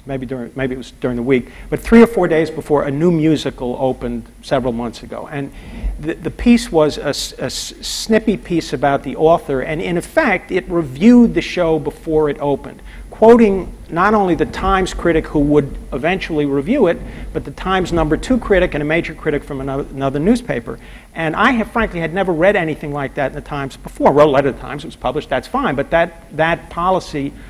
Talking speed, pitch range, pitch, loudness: 215 wpm, 140-185 Hz, 155 Hz, -16 LUFS